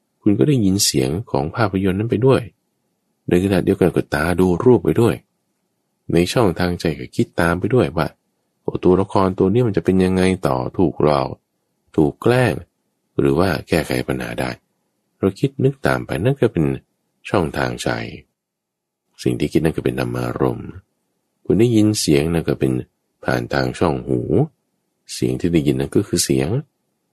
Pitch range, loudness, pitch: 65-95 Hz, -19 LUFS, 85 Hz